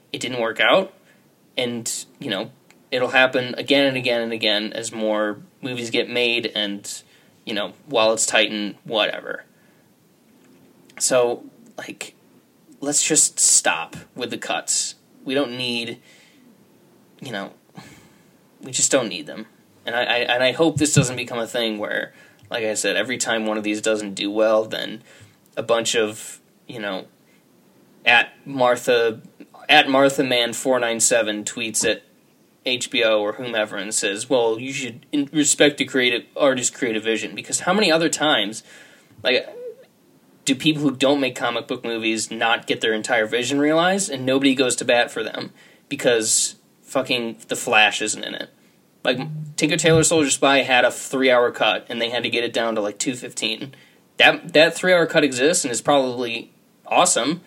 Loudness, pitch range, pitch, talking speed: -20 LUFS, 115-140 Hz, 125 Hz, 165 wpm